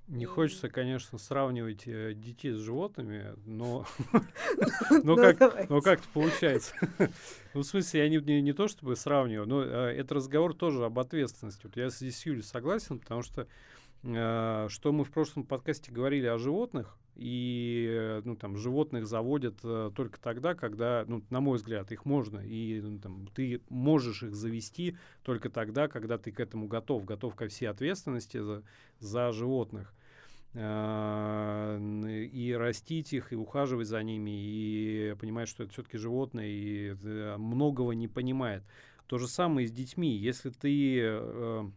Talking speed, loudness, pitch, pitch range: 140 wpm, -32 LUFS, 120 Hz, 110-140 Hz